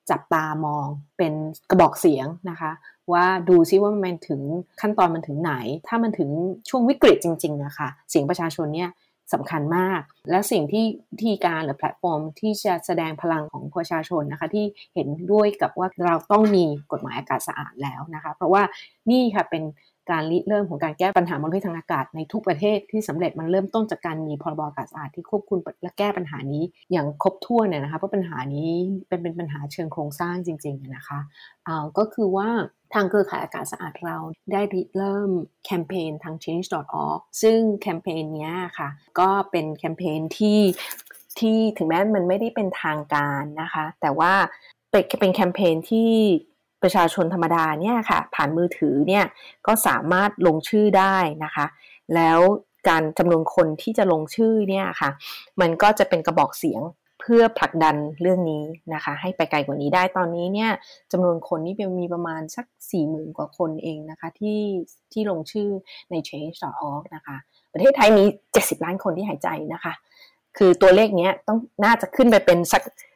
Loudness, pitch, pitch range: -22 LUFS, 175 Hz, 155-200 Hz